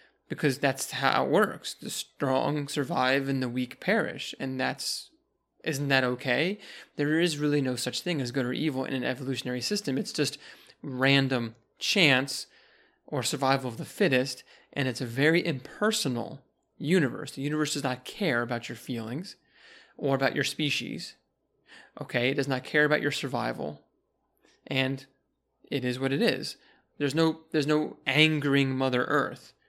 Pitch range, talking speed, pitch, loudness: 130-150 Hz, 160 wpm, 140 Hz, -28 LUFS